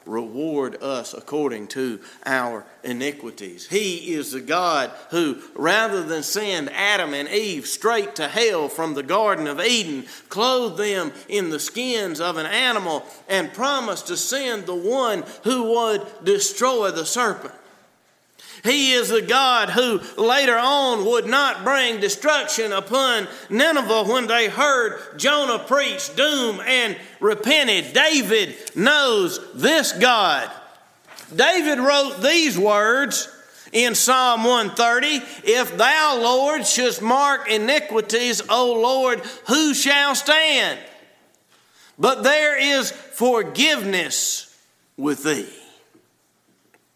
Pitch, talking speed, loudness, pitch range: 245 Hz, 120 wpm, -19 LUFS, 205-280 Hz